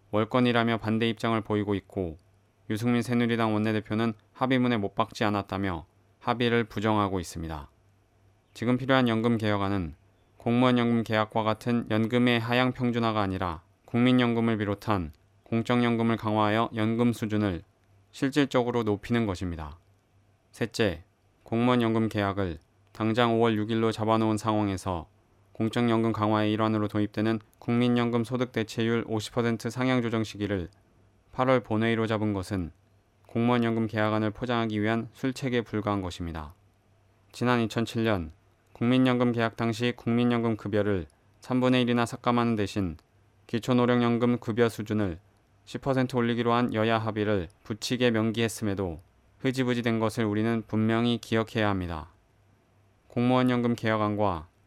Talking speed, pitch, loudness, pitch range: 320 characters per minute, 110 Hz, -27 LUFS, 100-120 Hz